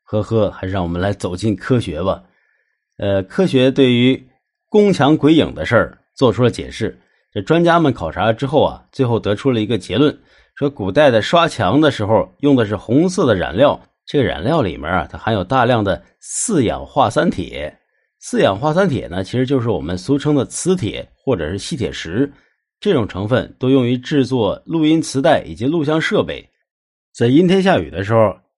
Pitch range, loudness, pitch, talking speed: 105-150 Hz, -16 LUFS, 130 Hz, 280 characters per minute